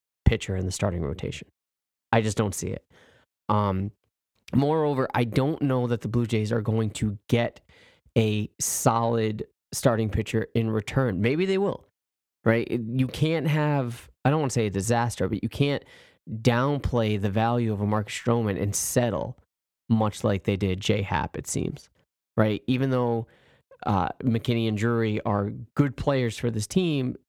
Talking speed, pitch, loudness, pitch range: 165 wpm, 115 Hz, -26 LUFS, 100-125 Hz